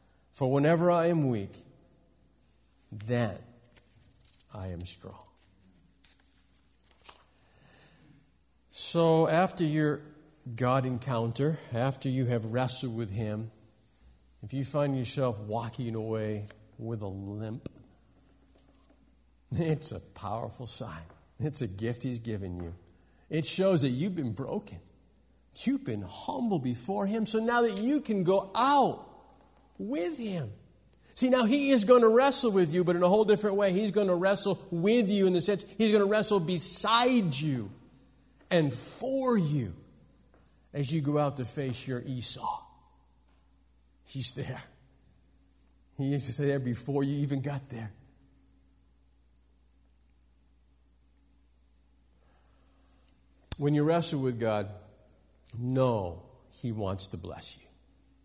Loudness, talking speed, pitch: -29 LUFS, 125 wpm, 120 Hz